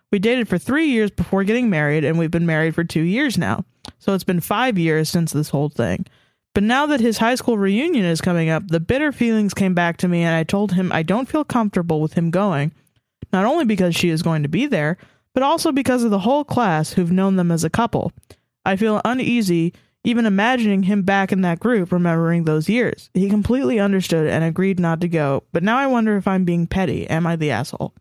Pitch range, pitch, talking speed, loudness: 165-225 Hz, 190 Hz, 230 wpm, -19 LUFS